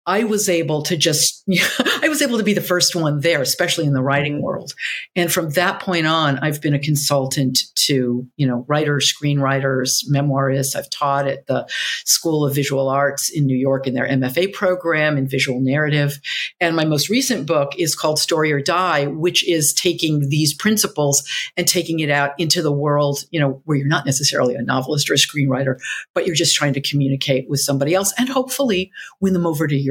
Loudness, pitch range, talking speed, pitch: -18 LUFS, 140-175 Hz, 205 wpm, 150 Hz